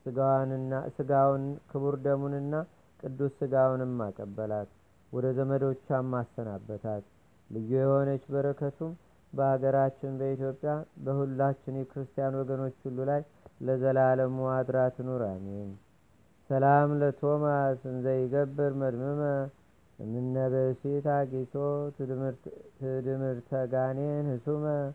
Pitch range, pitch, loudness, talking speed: 130-140 Hz, 135 Hz, -30 LUFS, 70 wpm